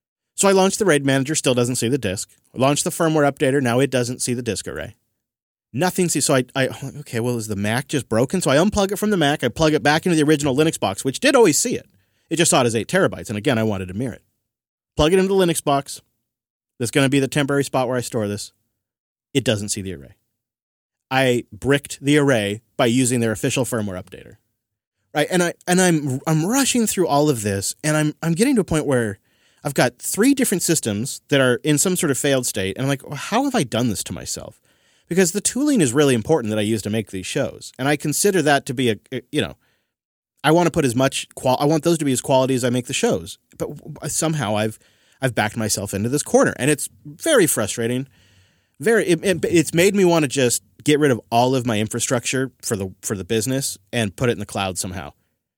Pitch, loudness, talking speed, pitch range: 130 Hz, -20 LUFS, 245 wpm, 115-155 Hz